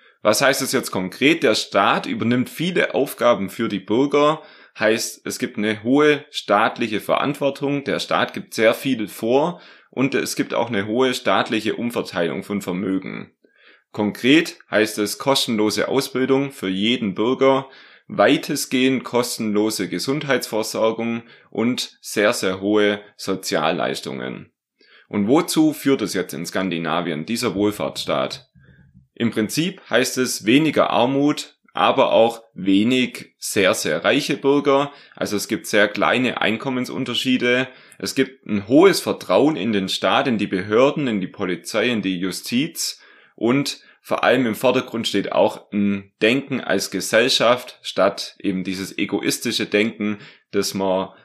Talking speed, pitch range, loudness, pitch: 135 wpm, 100-135 Hz, -20 LUFS, 115 Hz